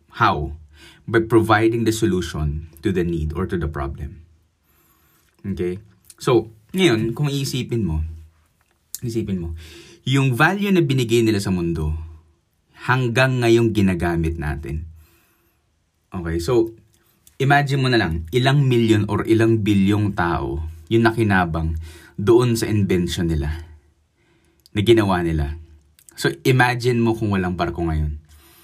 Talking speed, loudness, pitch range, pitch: 125 wpm, -20 LUFS, 80-115 Hz, 90 Hz